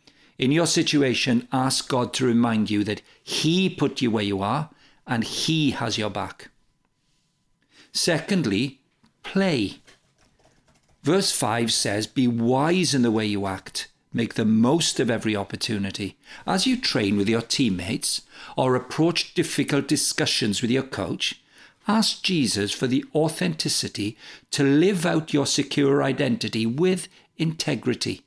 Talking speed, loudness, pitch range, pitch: 135 wpm, -23 LUFS, 110-160 Hz, 130 Hz